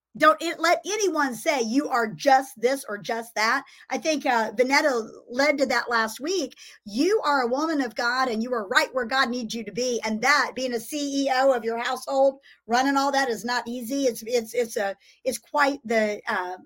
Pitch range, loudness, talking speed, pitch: 235-280 Hz, -24 LUFS, 215 wpm, 255 Hz